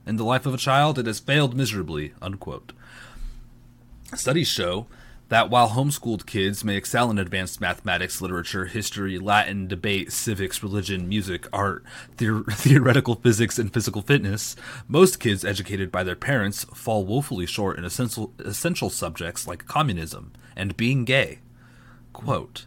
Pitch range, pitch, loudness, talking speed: 95-125 Hz, 110 Hz, -24 LUFS, 145 wpm